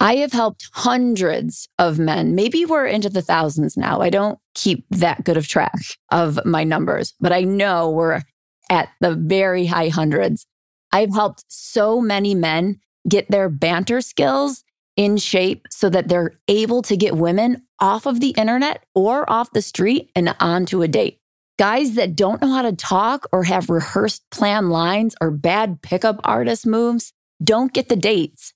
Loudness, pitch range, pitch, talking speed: -18 LUFS, 170-225 Hz, 195 Hz, 170 wpm